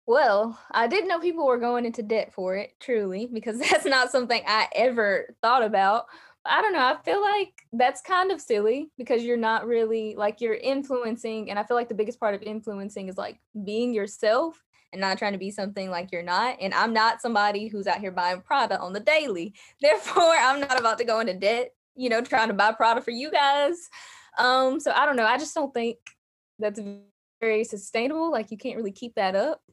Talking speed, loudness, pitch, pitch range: 215 wpm, -25 LUFS, 230 Hz, 210-265 Hz